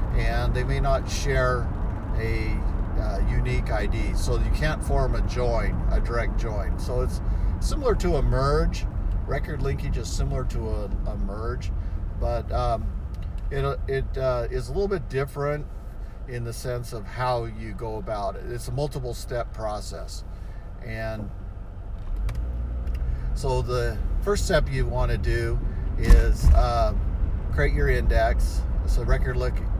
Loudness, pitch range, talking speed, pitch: -27 LUFS, 85-115 Hz, 145 wpm, 100 Hz